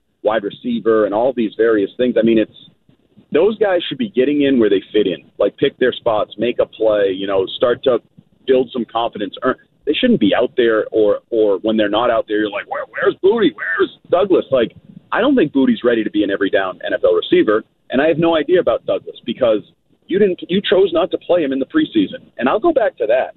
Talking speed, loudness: 235 wpm, -16 LUFS